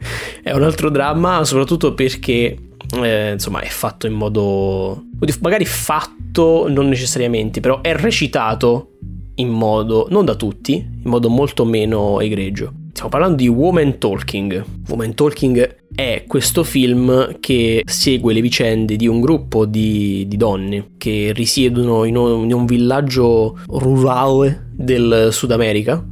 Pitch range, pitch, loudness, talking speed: 110-135 Hz, 120 Hz, -16 LUFS, 140 wpm